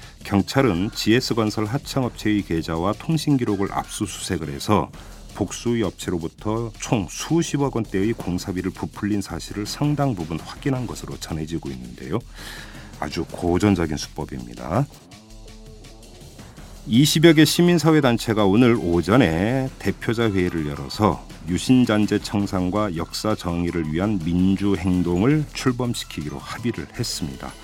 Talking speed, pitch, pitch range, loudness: 295 characters per minute, 105 Hz, 90-125 Hz, -22 LUFS